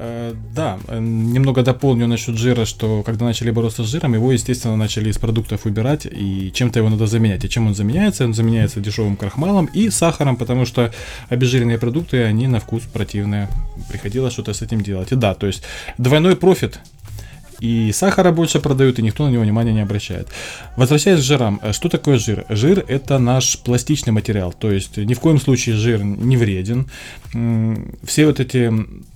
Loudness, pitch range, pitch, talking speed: -17 LUFS, 110-130 Hz, 115 Hz, 175 wpm